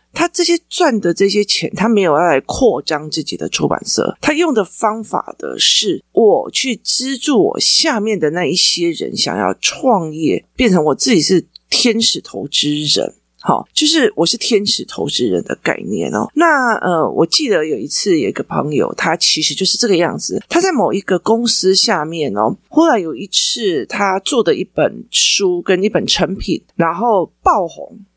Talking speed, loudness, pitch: 260 characters per minute, -14 LUFS, 225 Hz